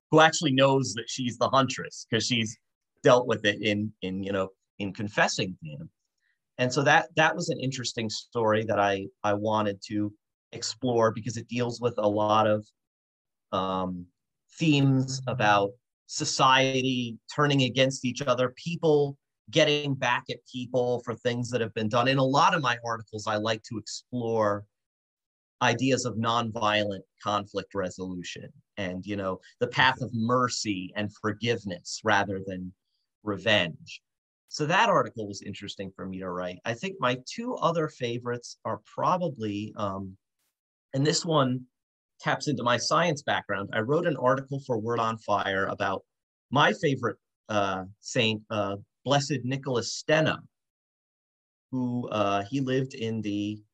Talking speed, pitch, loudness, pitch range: 150 wpm, 115 Hz, -27 LUFS, 105-130 Hz